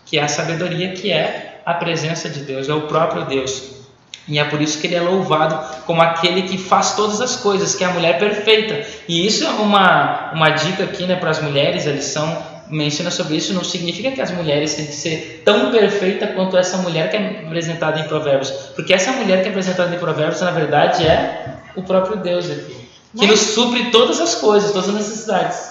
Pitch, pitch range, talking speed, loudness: 175 Hz, 155-195 Hz, 215 wpm, -17 LUFS